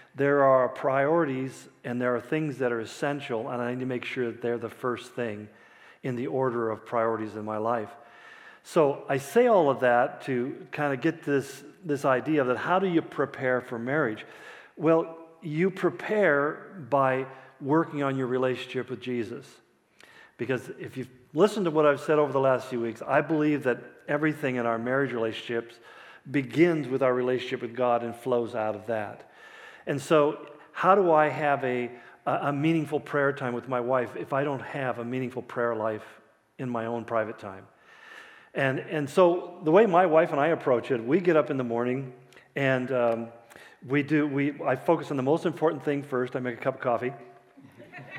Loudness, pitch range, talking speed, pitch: -27 LUFS, 120-150 Hz, 195 wpm, 130 Hz